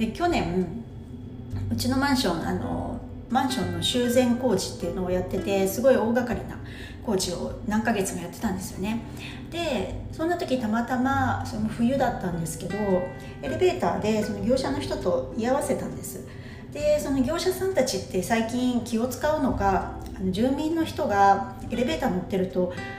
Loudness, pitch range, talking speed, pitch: -26 LUFS, 185-265 Hz, 315 characters per minute, 225 Hz